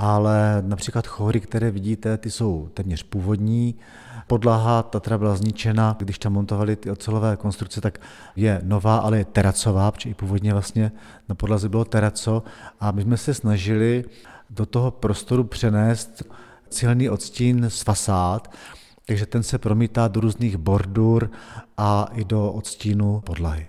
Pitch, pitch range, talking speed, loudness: 110 Hz, 105-115 Hz, 145 wpm, -22 LUFS